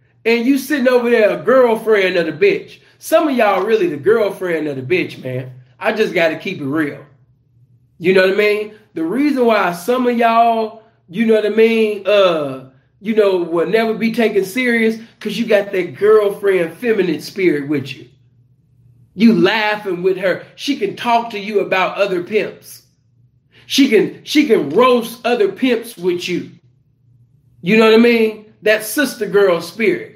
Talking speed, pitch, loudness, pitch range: 175 wpm, 205 Hz, -15 LUFS, 160-230 Hz